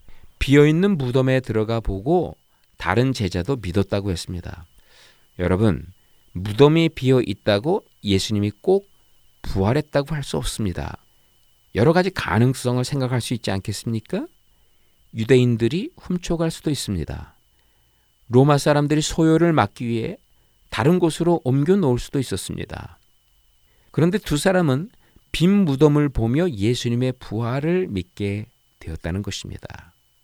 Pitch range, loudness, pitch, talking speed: 100-150 Hz, -21 LUFS, 120 Hz, 285 characters per minute